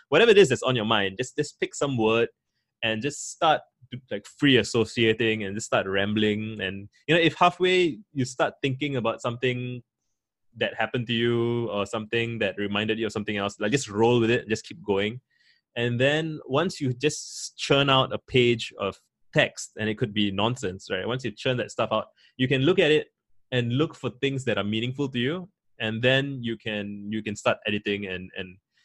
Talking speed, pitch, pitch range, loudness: 210 wpm, 120 Hz, 110-135 Hz, -25 LUFS